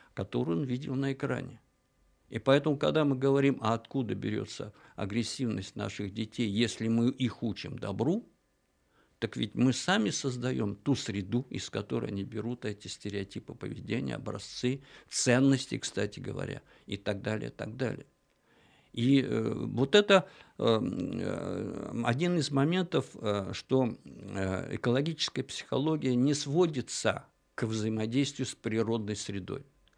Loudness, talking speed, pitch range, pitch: -31 LUFS, 120 wpm, 105-135 Hz, 120 Hz